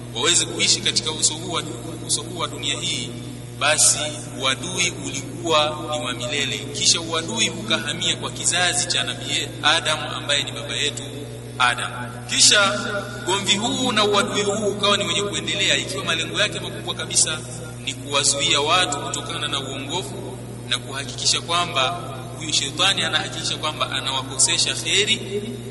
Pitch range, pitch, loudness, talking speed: 115-155 Hz, 125 Hz, -20 LUFS, 135 wpm